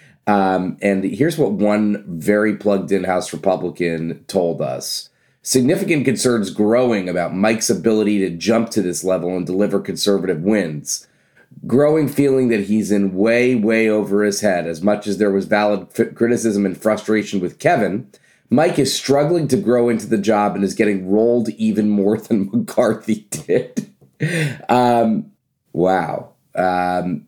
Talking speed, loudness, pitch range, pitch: 150 wpm, -18 LUFS, 95-115 Hz, 105 Hz